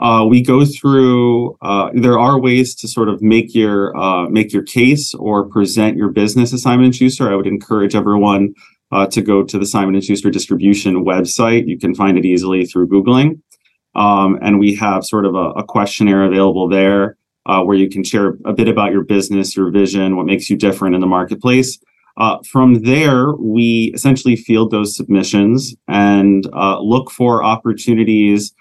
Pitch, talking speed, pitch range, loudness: 105 Hz, 185 wpm, 100-120 Hz, -13 LUFS